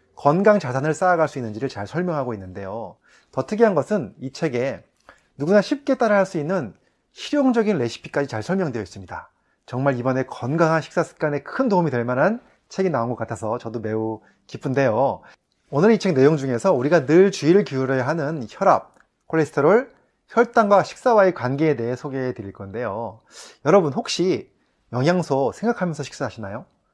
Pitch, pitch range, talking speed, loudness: 155 Hz, 125-190 Hz, 365 characters per minute, -21 LUFS